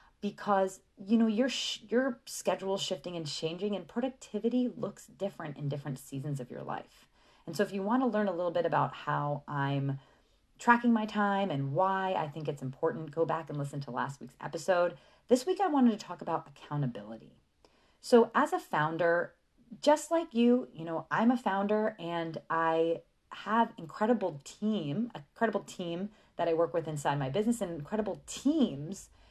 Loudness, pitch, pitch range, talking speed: -32 LUFS, 185 Hz, 155-225 Hz, 180 wpm